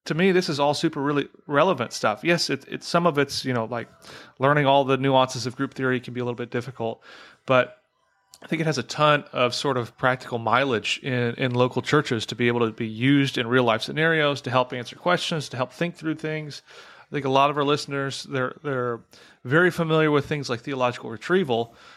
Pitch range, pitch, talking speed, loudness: 125-150 Hz, 135 Hz, 225 wpm, -23 LUFS